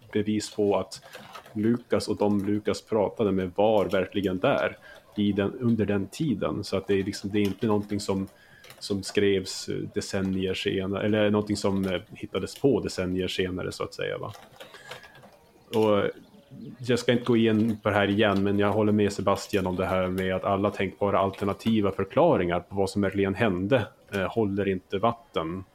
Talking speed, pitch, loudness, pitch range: 170 wpm, 100 Hz, -26 LUFS, 95-105 Hz